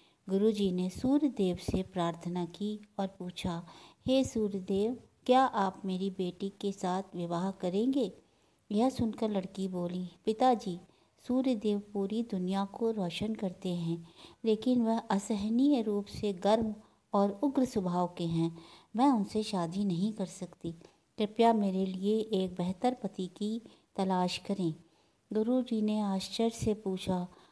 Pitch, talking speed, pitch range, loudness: 200 Hz, 140 wpm, 185-220 Hz, -32 LUFS